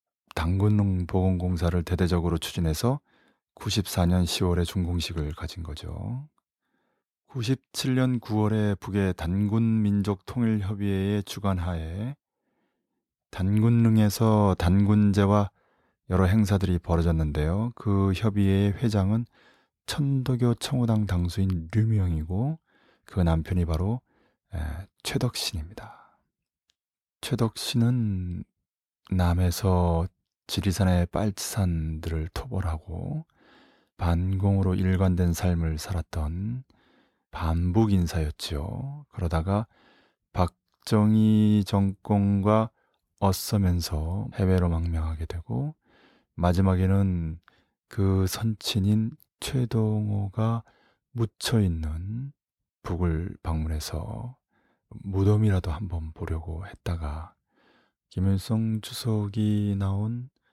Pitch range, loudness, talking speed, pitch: 90-110 Hz, -26 LUFS, 205 characters per minute, 95 Hz